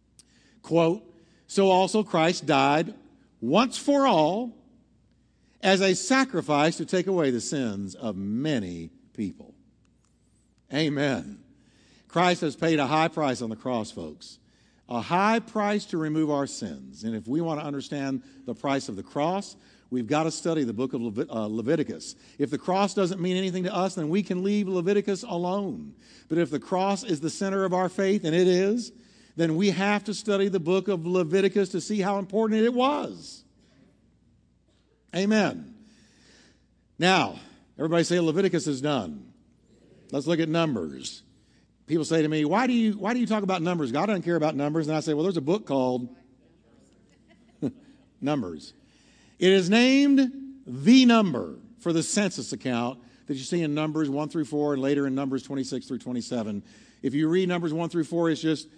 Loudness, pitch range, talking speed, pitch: -26 LUFS, 145-200 Hz, 175 wpm, 170 Hz